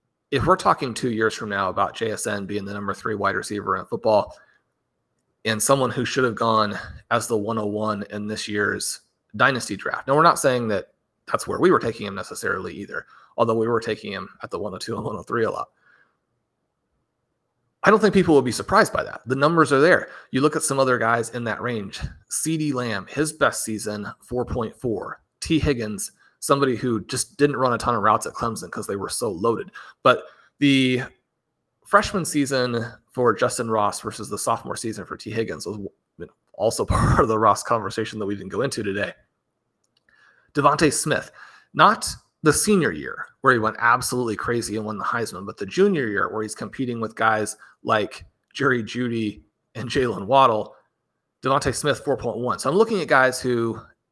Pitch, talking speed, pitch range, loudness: 120 Hz, 190 wpm, 110-135 Hz, -22 LUFS